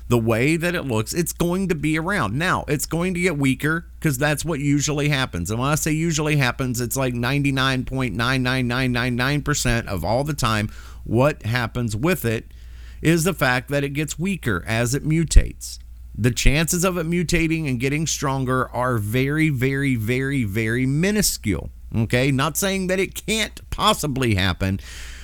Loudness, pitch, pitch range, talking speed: -21 LUFS, 135 Hz, 120-160 Hz, 165 wpm